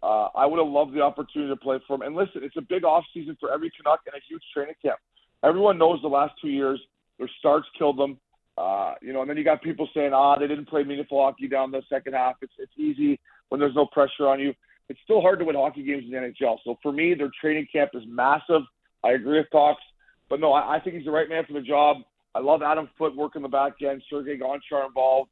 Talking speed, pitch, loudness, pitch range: 260 wpm, 145 Hz, -24 LUFS, 135-155 Hz